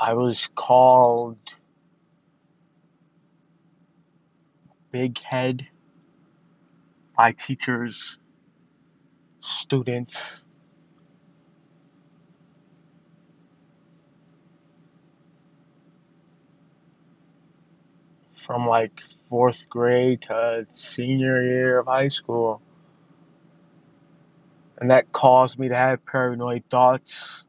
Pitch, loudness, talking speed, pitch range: 125 Hz, -21 LUFS, 55 wpm, 120-145 Hz